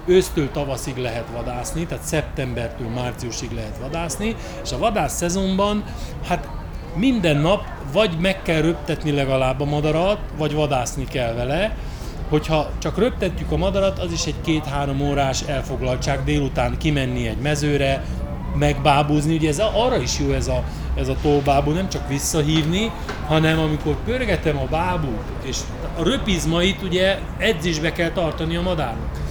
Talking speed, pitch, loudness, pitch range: 145 wpm, 150 Hz, -21 LUFS, 135-170 Hz